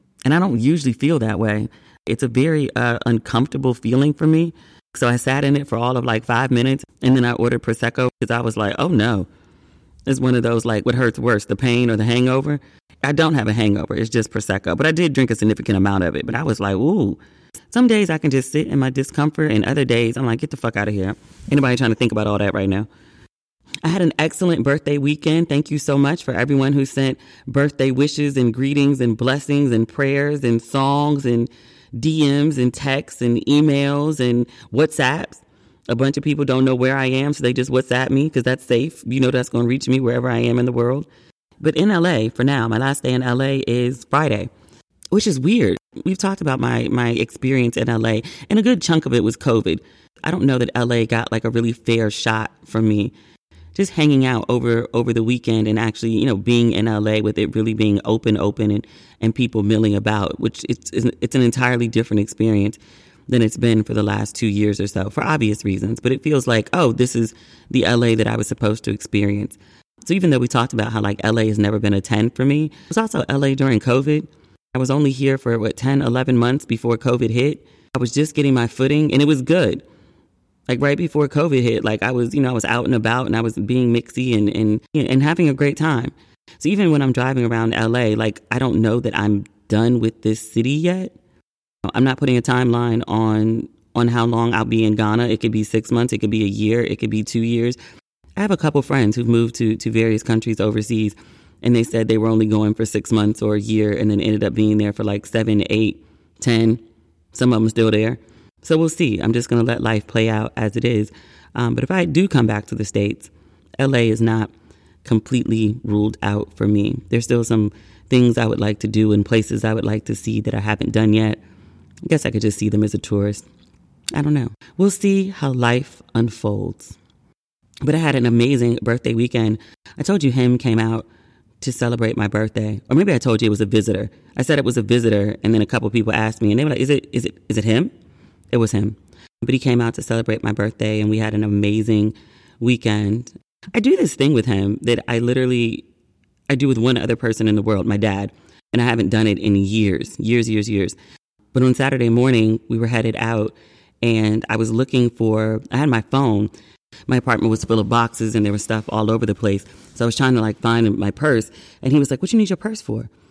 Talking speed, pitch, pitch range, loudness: 235 wpm, 115 Hz, 110-130 Hz, -19 LUFS